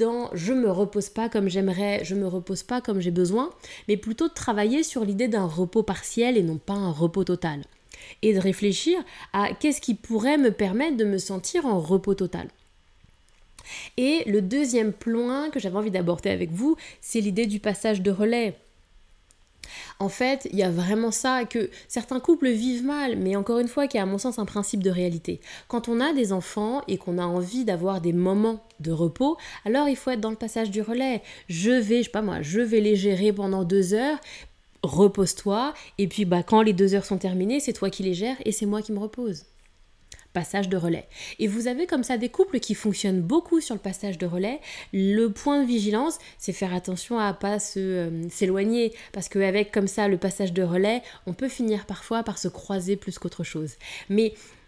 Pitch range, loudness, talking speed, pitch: 190-235 Hz, -25 LUFS, 210 wpm, 210 Hz